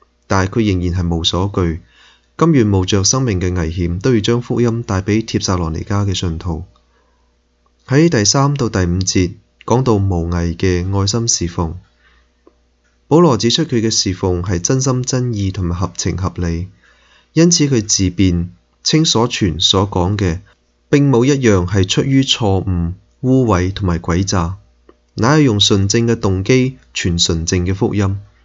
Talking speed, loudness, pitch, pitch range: 230 characters per minute, -15 LUFS, 95 Hz, 90-115 Hz